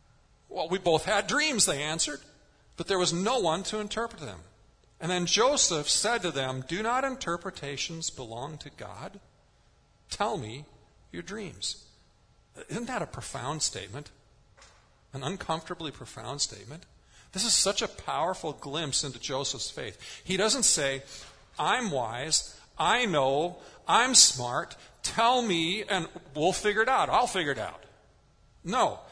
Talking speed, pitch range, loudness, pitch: 145 wpm, 140-205 Hz, -27 LUFS, 165 Hz